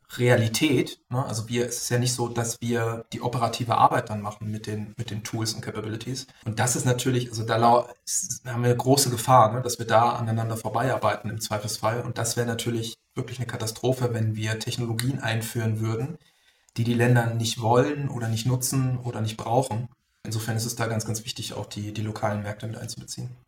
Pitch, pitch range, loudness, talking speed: 115 Hz, 110-125 Hz, -26 LUFS, 210 wpm